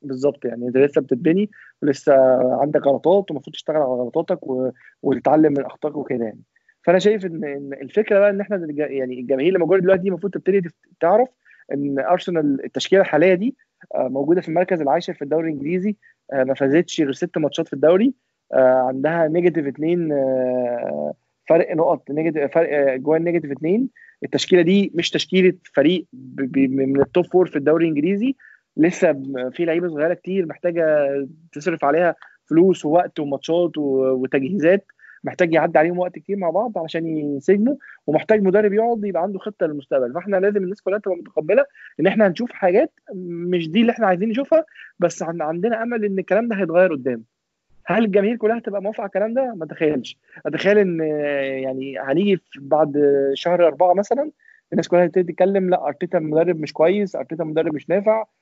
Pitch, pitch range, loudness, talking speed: 170 Hz, 145-195 Hz, -20 LUFS, 160 wpm